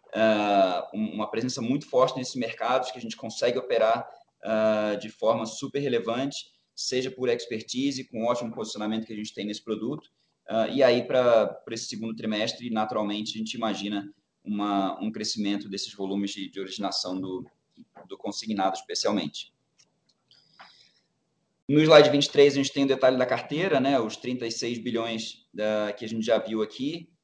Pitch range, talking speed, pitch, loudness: 105-130 Hz, 165 wpm, 110 Hz, -26 LUFS